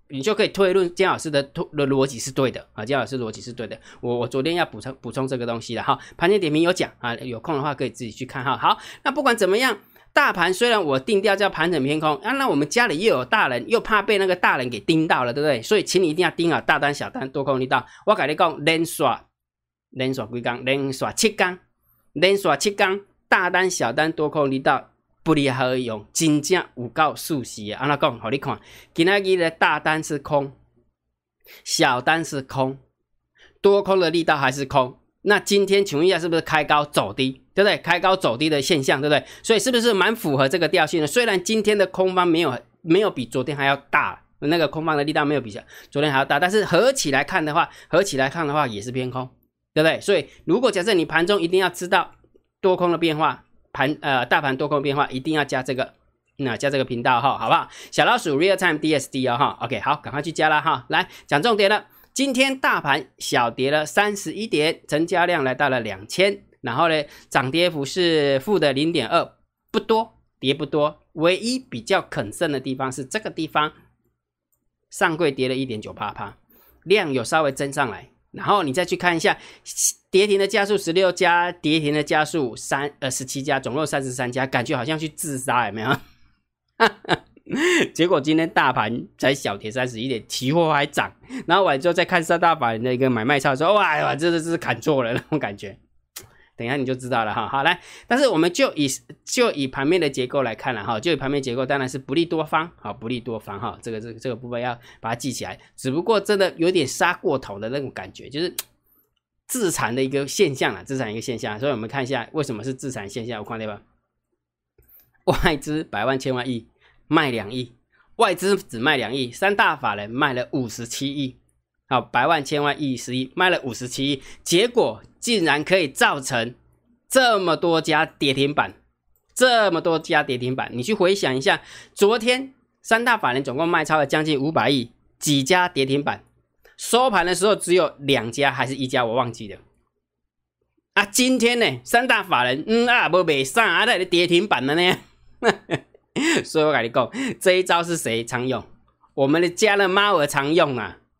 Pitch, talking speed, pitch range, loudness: 145 Hz, 305 characters per minute, 130-180 Hz, -21 LUFS